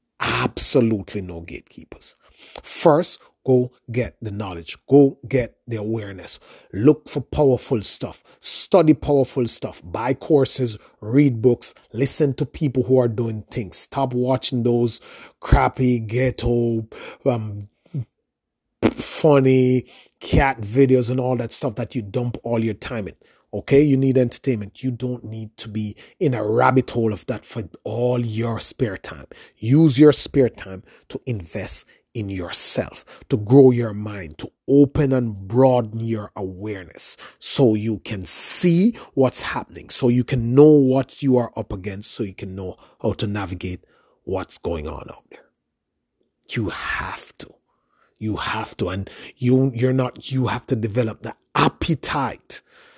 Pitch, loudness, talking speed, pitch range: 120 Hz, -20 LUFS, 150 wpm, 105-130 Hz